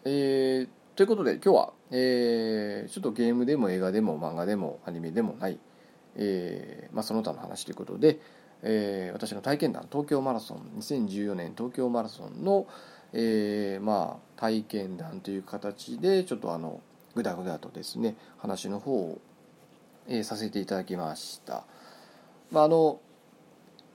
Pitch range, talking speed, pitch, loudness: 100-130 Hz, 295 characters per minute, 110 Hz, -30 LUFS